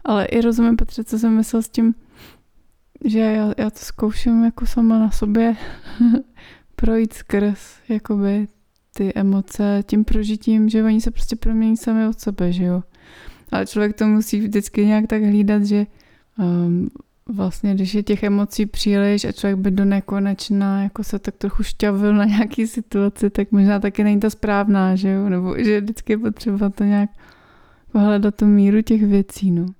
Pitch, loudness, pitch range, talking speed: 210 Hz, -19 LUFS, 200-225 Hz, 170 wpm